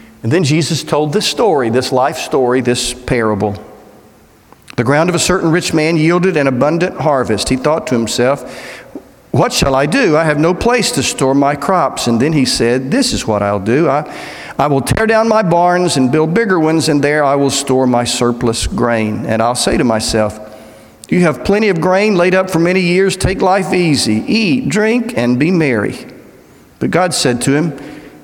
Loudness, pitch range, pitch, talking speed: -13 LUFS, 120-175 Hz, 145 Hz, 200 wpm